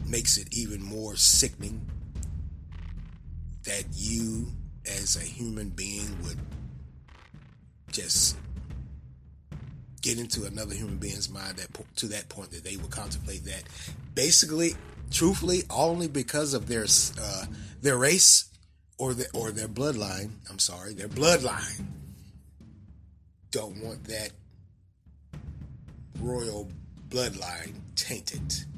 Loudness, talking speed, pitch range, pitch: -26 LUFS, 110 wpm, 80-115 Hz, 100 Hz